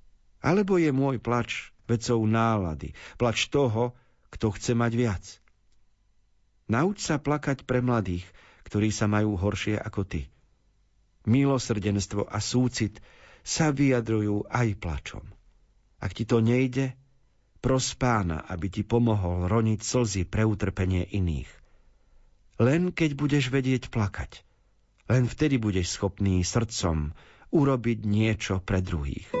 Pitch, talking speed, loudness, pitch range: 110 Hz, 120 wpm, -27 LUFS, 100-125 Hz